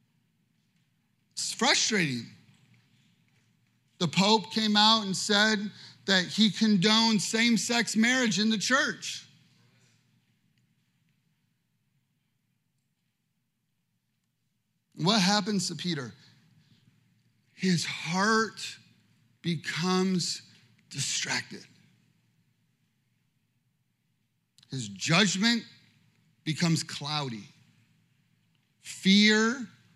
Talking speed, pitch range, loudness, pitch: 60 wpm, 140-210 Hz, -26 LUFS, 165 Hz